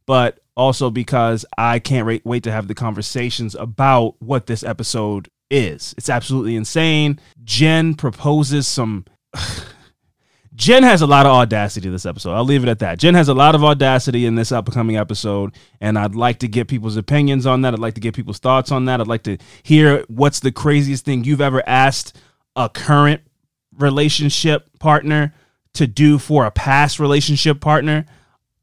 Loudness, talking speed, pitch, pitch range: -16 LUFS, 175 wpm, 130 Hz, 115-145 Hz